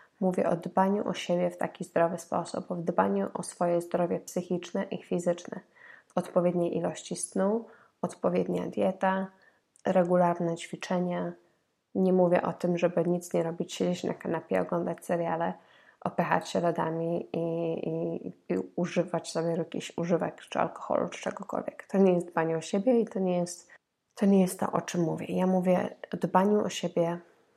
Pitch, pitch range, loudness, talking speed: 175 Hz, 170-185 Hz, -30 LUFS, 160 wpm